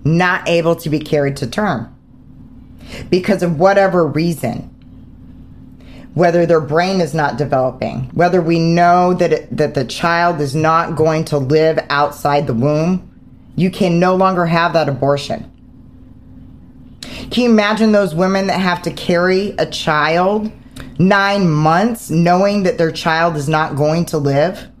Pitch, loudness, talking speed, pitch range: 165 Hz, -15 LUFS, 150 wpm, 145-180 Hz